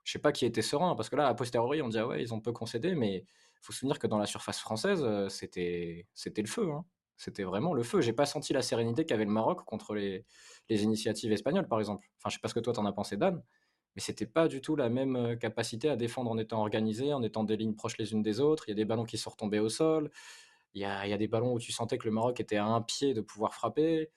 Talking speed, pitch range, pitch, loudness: 295 wpm, 105-130 Hz, 110 Hz, -33 LUFS